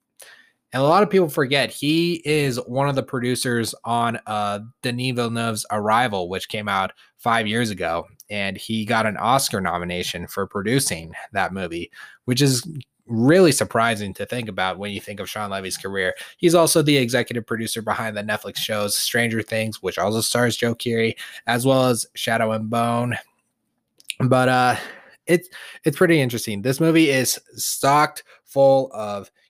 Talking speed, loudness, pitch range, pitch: 165 wpm, -21 LUFS, 105-135 Hz, 115 Hz